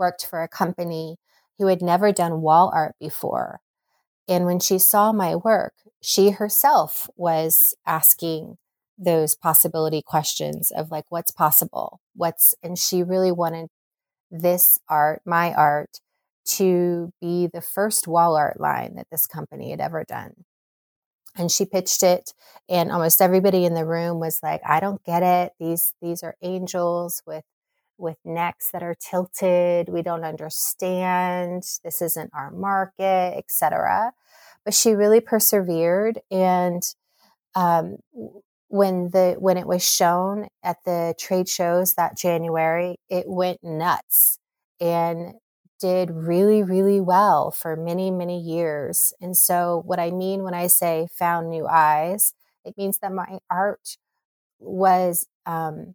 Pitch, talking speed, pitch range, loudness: 175 Hz, 140 wpm, 165-185 Hz, -20 LUFS